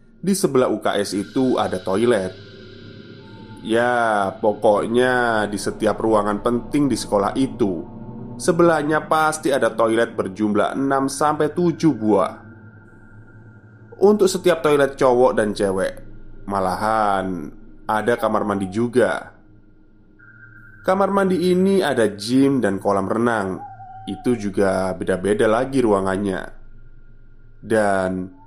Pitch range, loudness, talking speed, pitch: 105-130 Hz, -19 LUFS, 100 wpm, 110 Hz